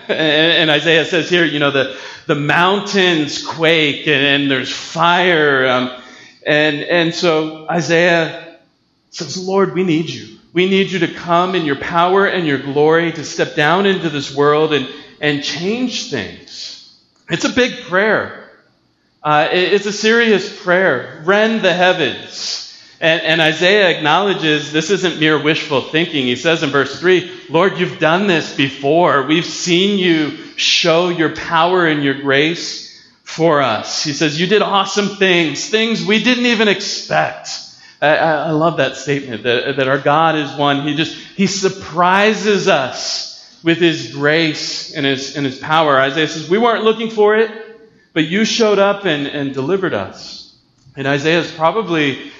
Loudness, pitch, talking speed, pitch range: -14 LUFS, 165 Hz, 165 wpm, 150-190 Hz